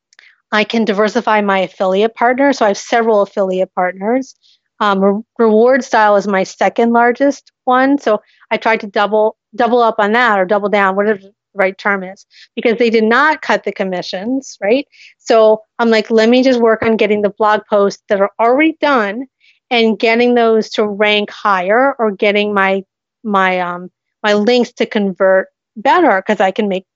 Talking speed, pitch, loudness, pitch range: 185 wpm, 215 Hz, -13 LUFS, 200-240 Hz